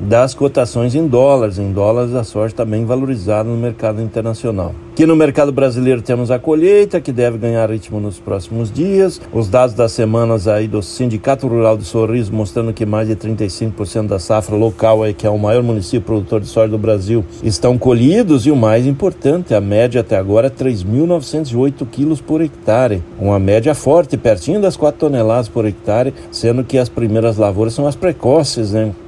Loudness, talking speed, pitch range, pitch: -14 LUFS, 185 wpm, 110-135 Hz, 115 Hz